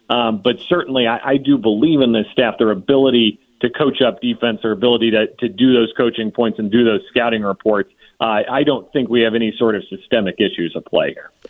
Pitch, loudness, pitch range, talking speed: 115 Hz, -16 LUFS, 110-125 Hz, 225 wpm